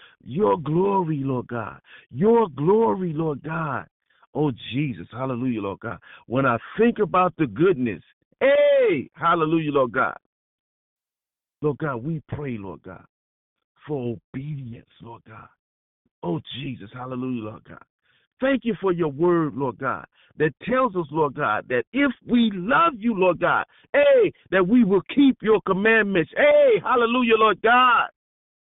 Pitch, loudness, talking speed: 165 Hz, -22 LUFS, 140 wpm